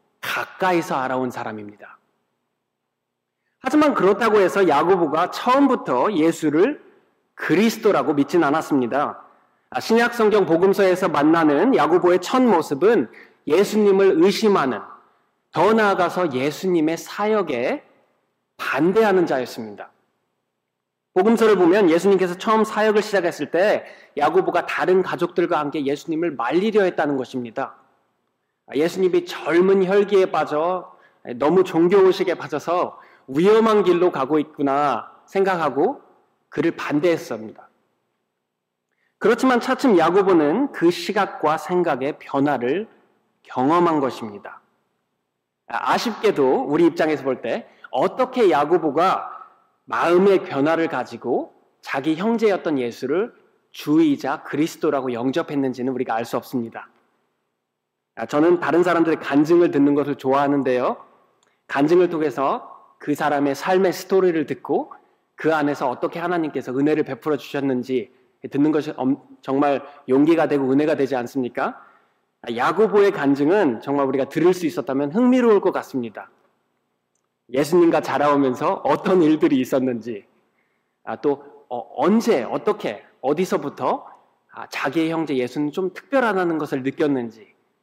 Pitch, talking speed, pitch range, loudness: 160 Hz, 295 characters per minute, 135-200 Hz, -20 LUFS